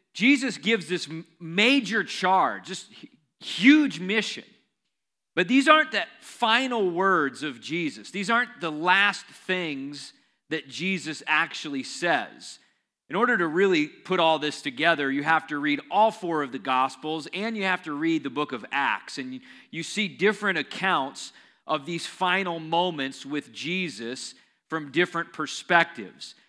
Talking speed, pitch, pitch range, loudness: 145 wpm, 180 Hz, 155-220 Hz, -25 LUFS